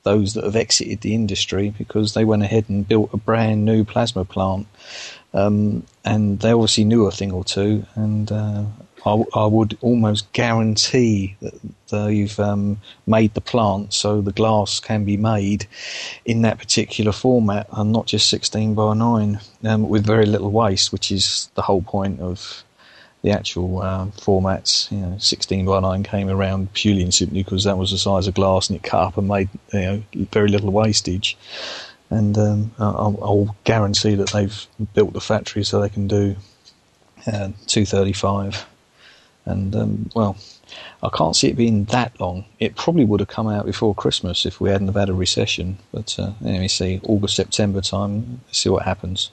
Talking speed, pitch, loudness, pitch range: 185 wpm, 105 Hz, -19 LUFS, 95-110 Hz